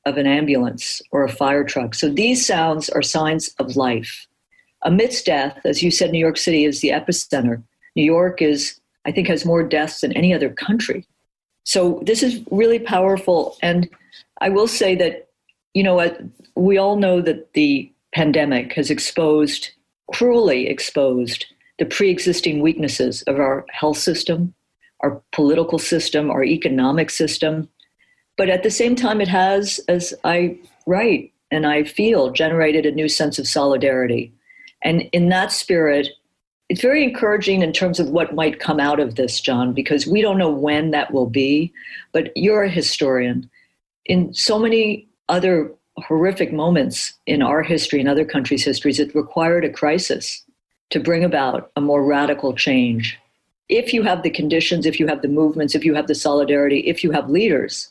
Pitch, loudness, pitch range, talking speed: 160 Hz, -18 LUFS, 145-180 Hz, 170 wpm